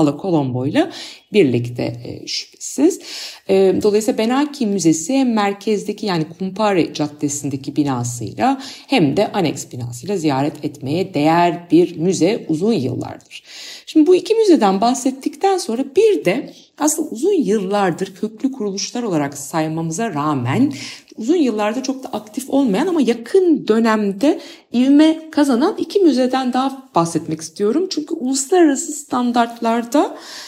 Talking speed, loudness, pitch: 115 wpm, -18 LUFS, 225 Hz